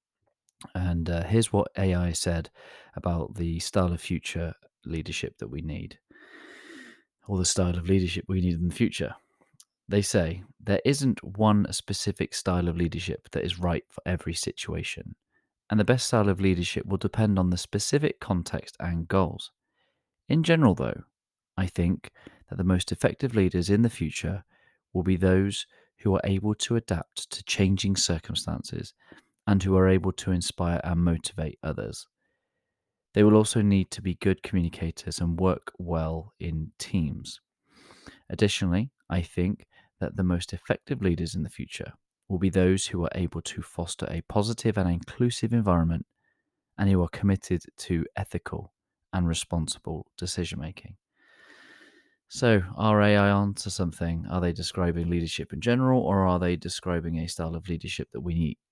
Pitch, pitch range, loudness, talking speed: 95 Hz, 85-105 Hz, -27 LUFS, 160 wpm